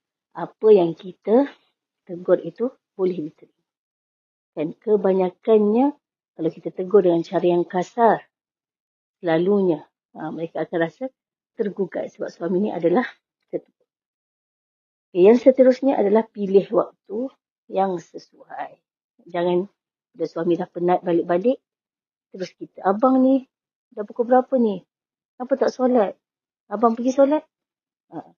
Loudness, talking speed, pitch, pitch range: -21 LUFS, 110 wpm, 200 Hz, 175-250 Hz